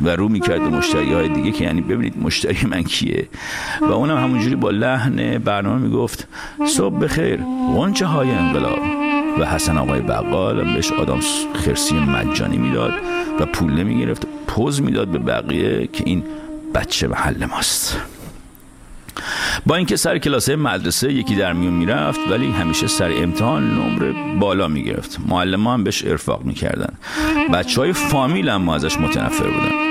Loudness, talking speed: -18 LUFS, 150 wpm